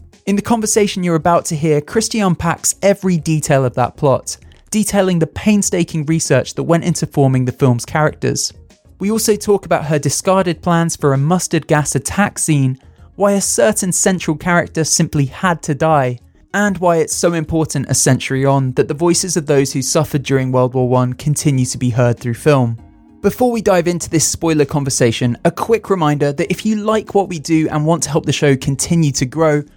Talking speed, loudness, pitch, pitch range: 200 wpm, -15 LUFS, 160 Hz, 135-180 Hz